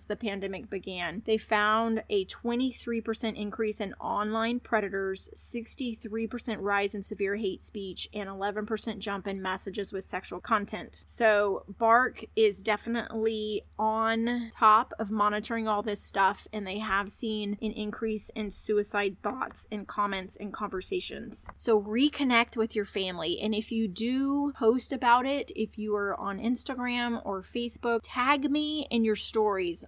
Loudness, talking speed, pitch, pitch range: -30 LUFS, 145 wpm, 215 Hz, 205-230 Hz